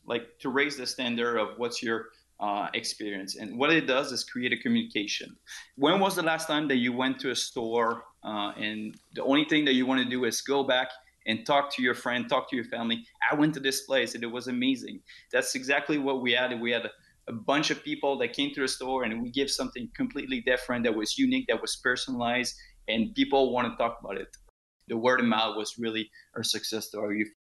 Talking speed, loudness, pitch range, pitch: 230 wpm, -28 LUFS, 115-145 Hz, 125 Hz